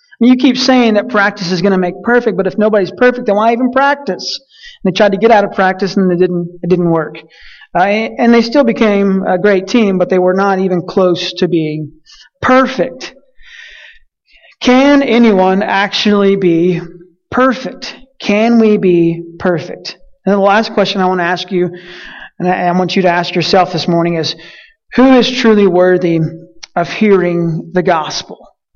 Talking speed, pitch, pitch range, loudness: 180 wpm, 195 Hz, 180-230 Hz, -11 LUFS